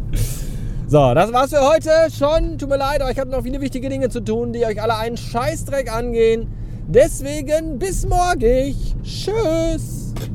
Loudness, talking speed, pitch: -19 LUFS, 160 wpm, 165 Hz